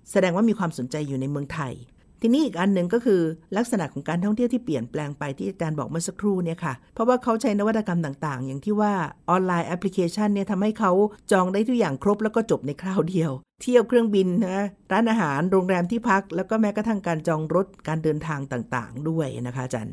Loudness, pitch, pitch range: -24 LUFS, 185 Hz, 155-210 Hz